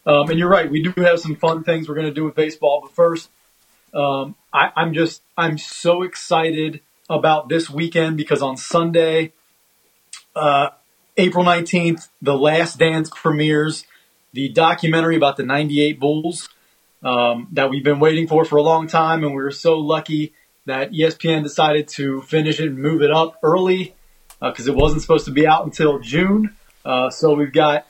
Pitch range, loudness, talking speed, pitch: 150-165 Hz, -18 LUFS, 180 wpm, 155 Hz